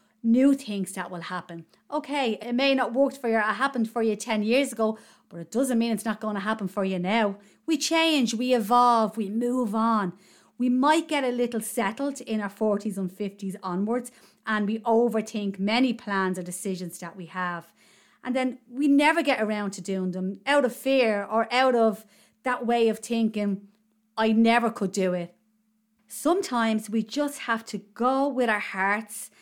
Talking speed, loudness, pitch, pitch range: 190 wpm, -25 LUFS, 220 Hz, 205-250 Hz